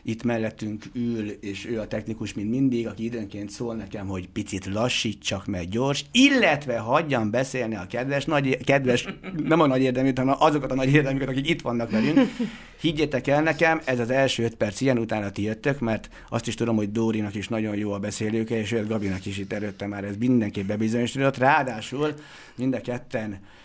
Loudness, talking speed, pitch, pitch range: -25 LUFS, 195 wpm, 115 Hz, 110-135 Hz